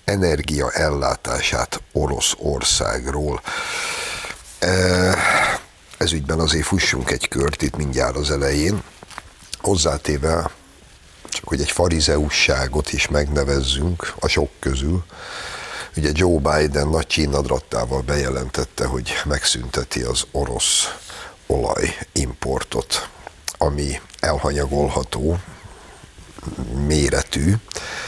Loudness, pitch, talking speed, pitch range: -20 LUFS, 75 Hz, 80 wpm, 70-90 Hz